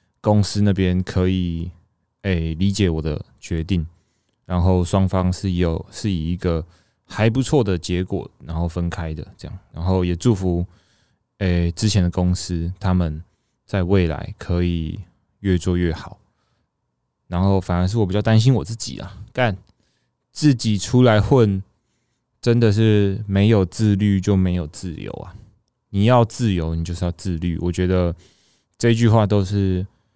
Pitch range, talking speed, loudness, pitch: 90-105 Hz, 220 characters per minute, -20 LUFS, 95 Hz